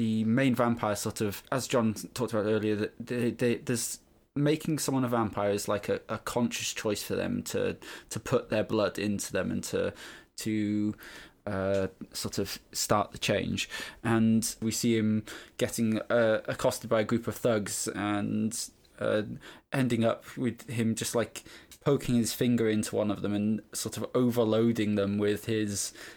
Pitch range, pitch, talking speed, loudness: 105-120 Hz, 110 Hz, 175 wpm, -30 LUFS